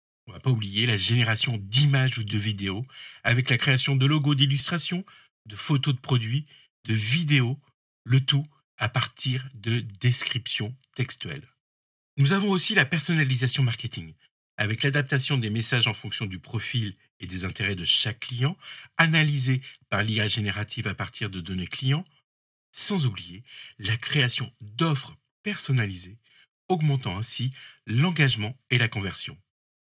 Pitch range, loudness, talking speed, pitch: 110-140 Hz, -25 LUFS, 145 wpm, 125 Hz